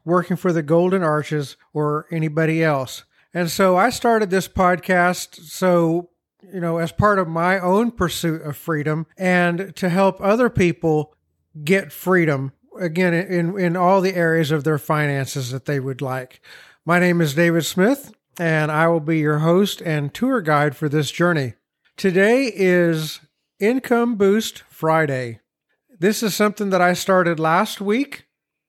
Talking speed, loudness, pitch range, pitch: 155 wpm, -19 LUFS, 155-190 Hz, 175 Hz